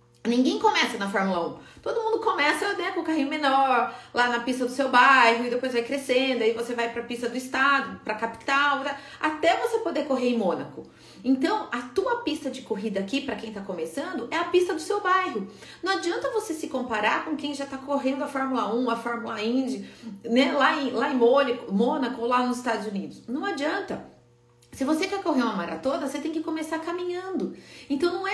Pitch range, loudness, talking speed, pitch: 235-320 Hz, -25 LUFS, 210 wpm, 270 Hz